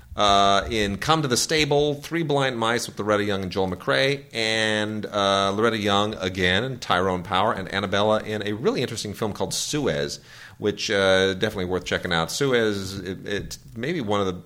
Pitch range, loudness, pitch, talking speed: 95-115 Hz, -23 LUFS, 105 Hz, 185 wpm